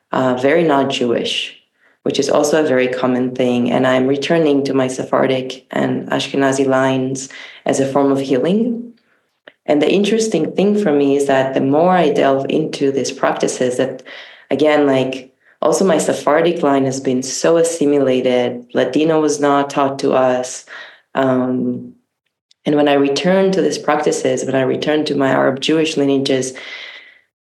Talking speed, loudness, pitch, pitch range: 160 wpm, -16 LUFS, 135 Hz, 130-150 Hz